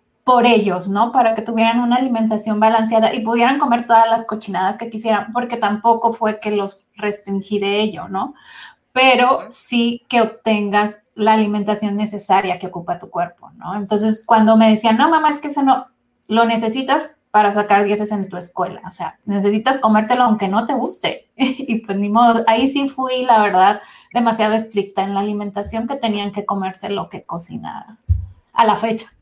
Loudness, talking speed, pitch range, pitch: -17 LUFS, 180 wpm, 205-235 Hz, 220 Hz